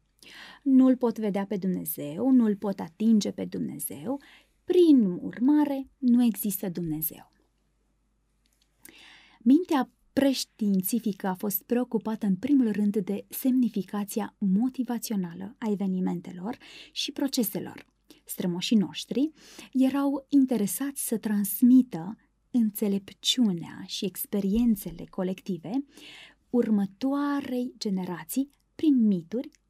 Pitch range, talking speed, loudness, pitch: 200-260 Hz, 90 wpm, -27 LUFS, 225 Hz